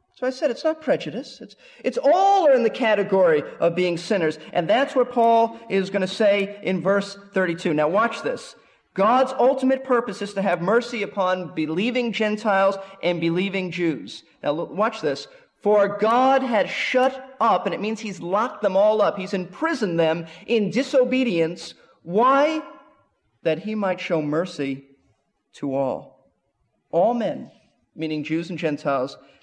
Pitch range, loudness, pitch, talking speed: 175-250 Hz, -22 LUFS, 205 Hz, 155 wpm